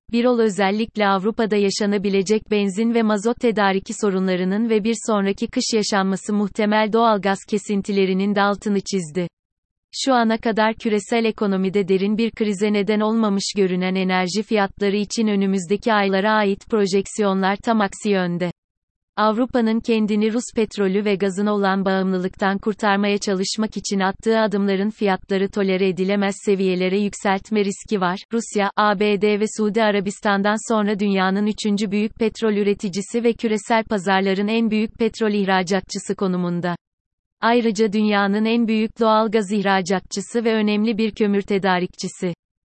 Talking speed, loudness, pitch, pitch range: 130 wpm, -20 LUFS, 205 Hz, 195-220 Hz